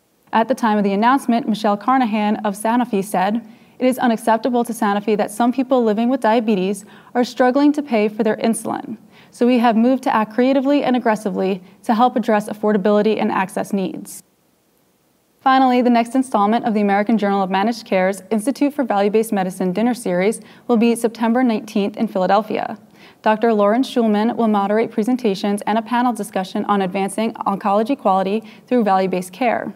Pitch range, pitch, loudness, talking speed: 205-245 Hz, 220 Hz, -18 LUFS, 170 wpm